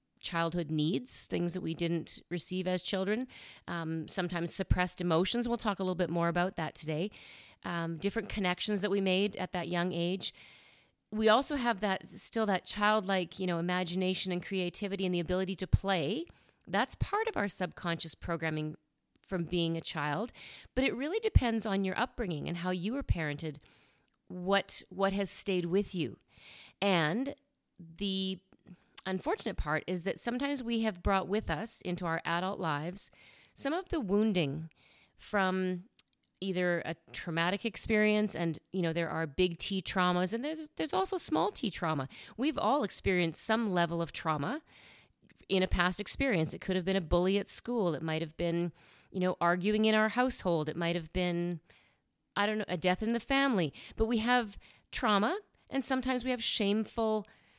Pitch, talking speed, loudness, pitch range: 185 Hz, 175 wpm, -32 LUFS, 170-215 Hz